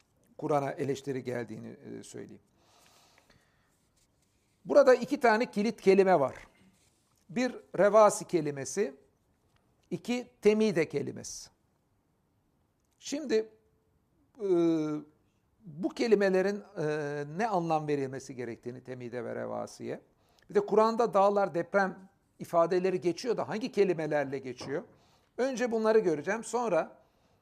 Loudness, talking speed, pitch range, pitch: -29 LUFS, 90 wpm, 140-215 Hz, 175 Hz